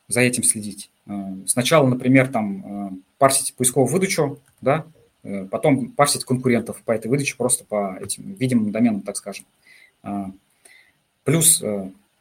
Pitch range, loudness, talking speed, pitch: 100-140 Hz, -20 LUFS, 120 wpm, 125 Hz